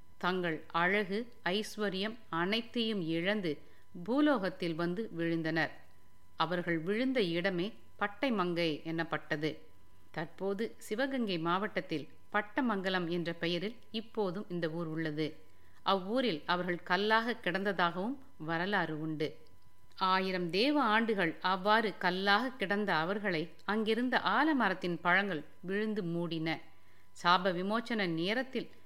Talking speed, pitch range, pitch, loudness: 90 wpm, 165-215 Hz, 180 Hz, -33 LUFS